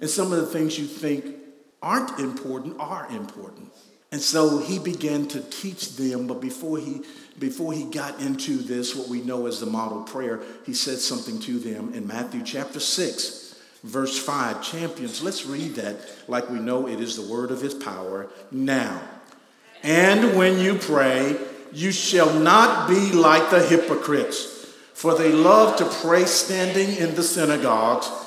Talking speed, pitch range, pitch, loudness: 170 wpm, 130-185 Hz, 155 Hz, -22 LUFS